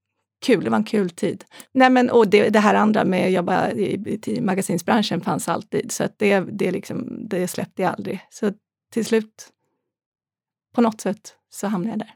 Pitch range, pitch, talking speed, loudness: 190-225 Hz, 210 Hz, 200 wpm, -21 LUFS